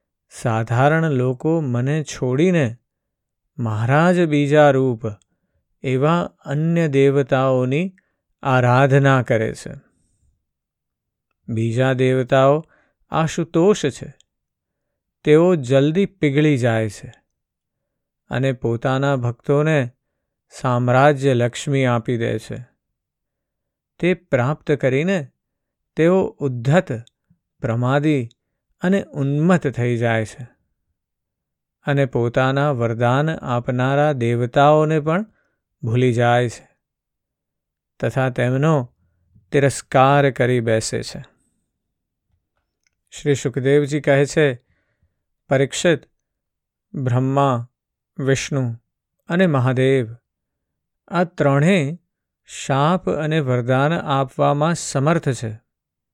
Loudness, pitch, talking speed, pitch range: -19 LUFS, 135 Hz, 80 wpm, 120-150 Hz